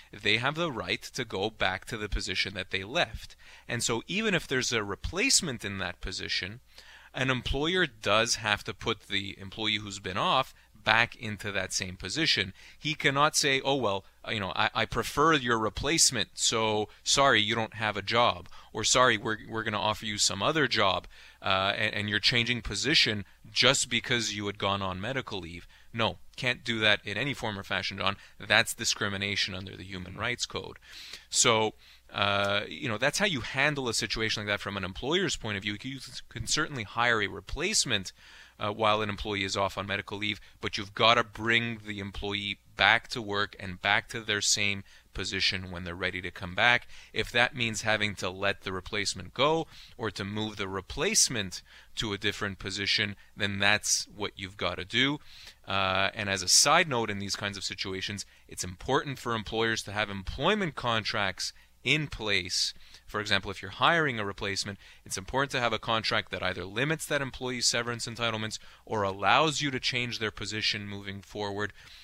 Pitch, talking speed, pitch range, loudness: 105 Hz, 190 wpm, 100-120 Hz, -28 LUFS